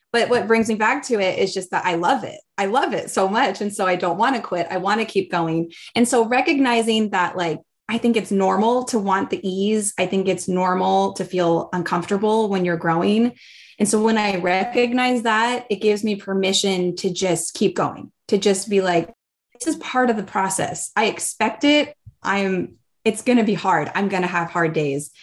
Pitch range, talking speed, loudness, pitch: 185-225 Hz, 220 wpm, -20 LUFS, 195 Hz